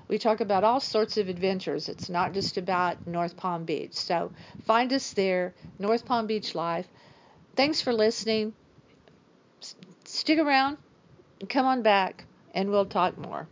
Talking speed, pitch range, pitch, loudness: 160 wpm, 185-230 Hz, 210 Hz, -27 LUFS